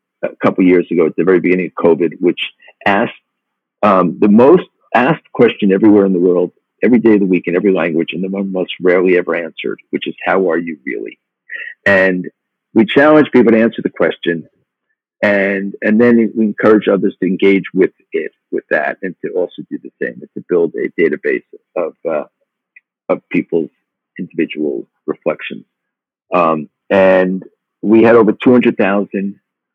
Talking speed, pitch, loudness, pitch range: 175 wpm, 100 Hz, -14 LUFS, 90-145 Hz